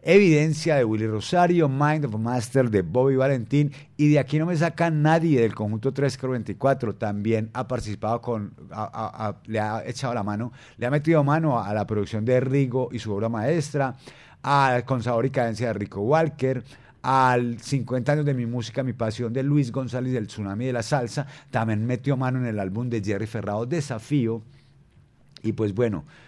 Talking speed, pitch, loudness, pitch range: 185 wpm, 125 Hz, -24 LUFS, 115-140 Hz